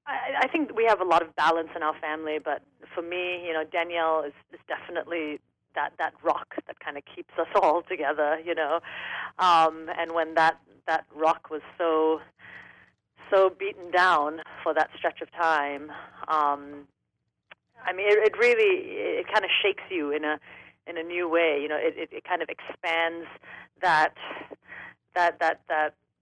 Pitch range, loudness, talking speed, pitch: 155-180 Hz, -26 LUFS, 180 wpm, 165 Hz